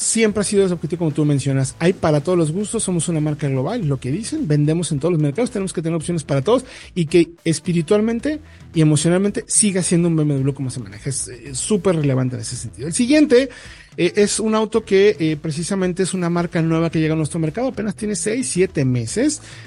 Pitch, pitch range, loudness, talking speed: 170 Hz, 150-205 Hz, -19 LUFS, 225 wpm